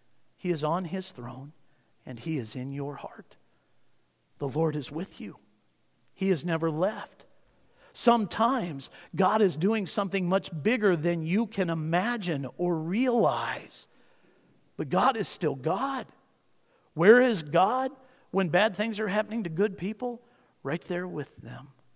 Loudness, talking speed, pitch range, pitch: -28 LUFS, 145 wpm, 155-215 Hz, 180 Hz